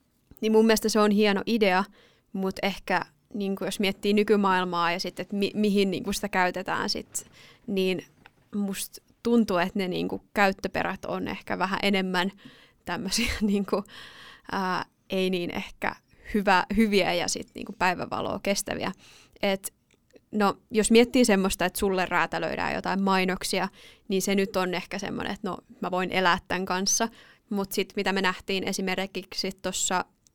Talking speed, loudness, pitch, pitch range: 150 wpm, -26 LUFS, 195 Hz, 185-210 Hz